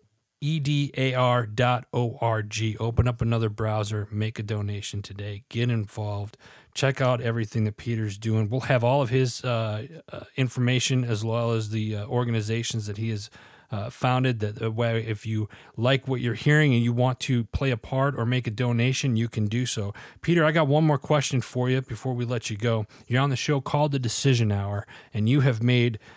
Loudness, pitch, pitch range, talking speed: -25 LUFS, 120 Hz, 110-130 Hz, 205 wpm